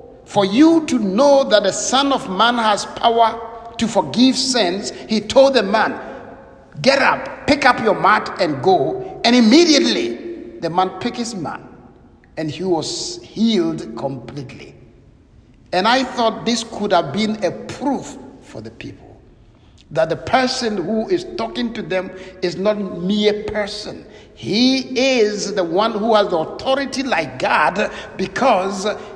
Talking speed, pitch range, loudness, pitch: 150 wpm, 190-255 Hz, -17 LUFS, 220 Hz